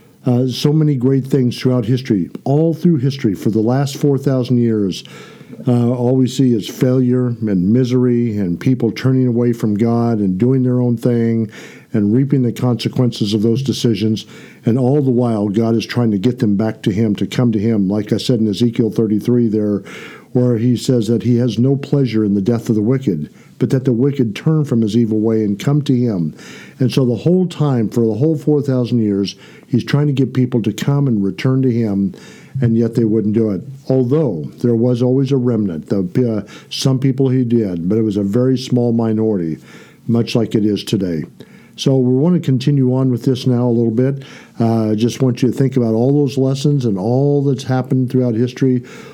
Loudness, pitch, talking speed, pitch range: -16 LUFS, 120 Hz, 210 wpm, 110-130 Hz